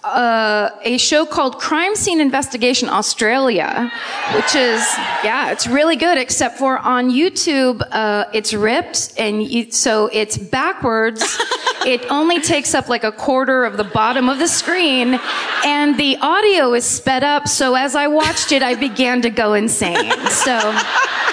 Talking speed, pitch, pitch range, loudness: 160 wpm, 260 Hz, 235-305 Hz, -15 LUFS